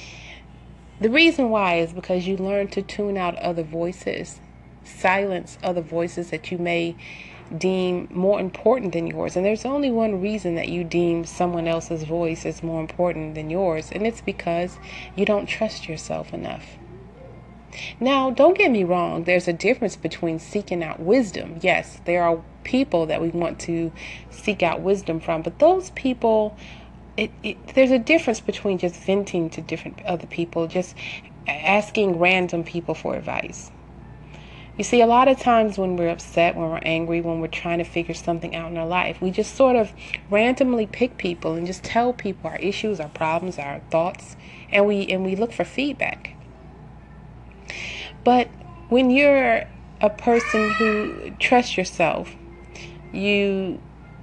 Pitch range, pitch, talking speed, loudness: 170-215 Hz, 180 Hz, 165 wpm, -22 LUFS